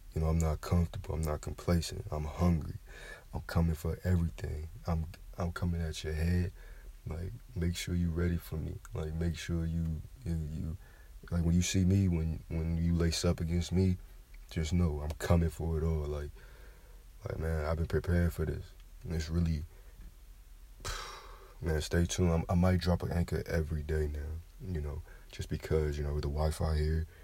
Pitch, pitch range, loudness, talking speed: 85 Hz, 80-90 Hz, -34 LUFS, 185 wpm